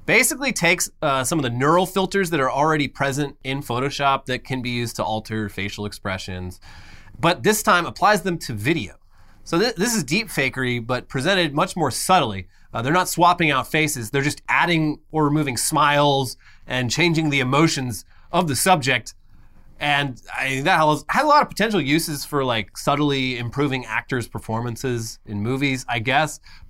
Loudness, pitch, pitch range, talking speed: -21 LUFS, 140 Hz, 115-165 Hz, 180 wpm